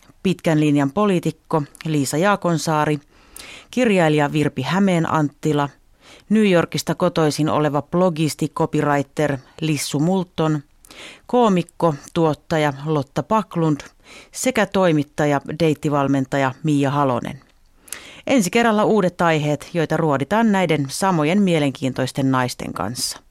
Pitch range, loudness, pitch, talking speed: 145-180 Hz, -19 LUFS, 155 Hz, 95 wpm